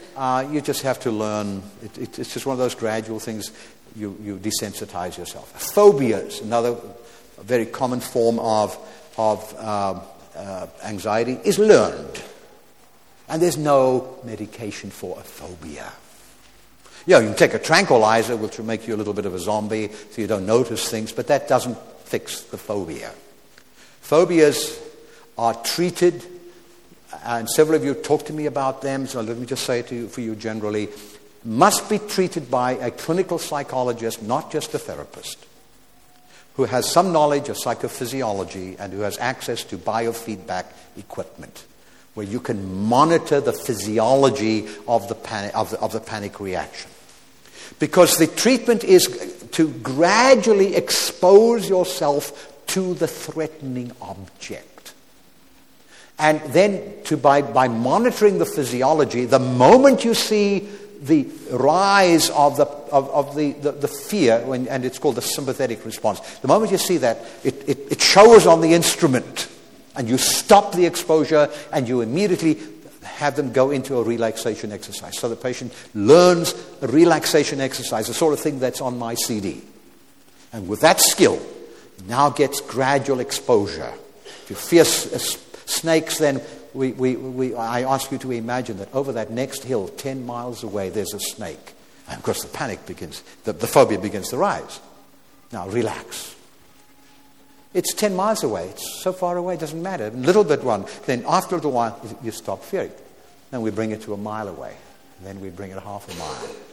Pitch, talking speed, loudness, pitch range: 130 Hz, 165 wpm, -20 LUFS, 110-160 Hz